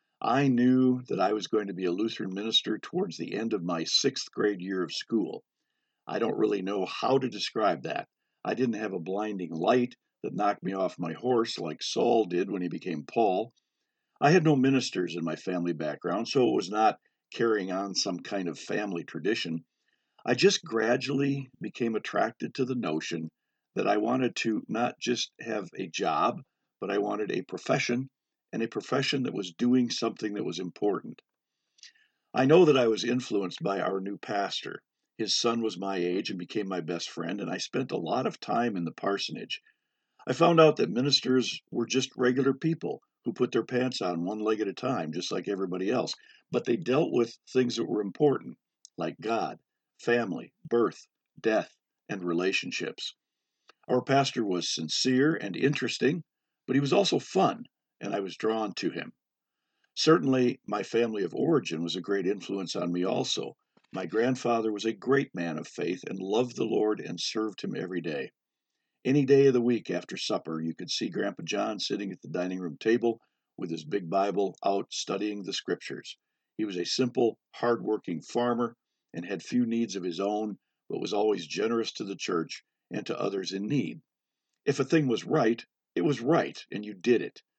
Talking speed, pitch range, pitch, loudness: 190 wpm, 95-130 Hz, 115 Hz, -29 LUFS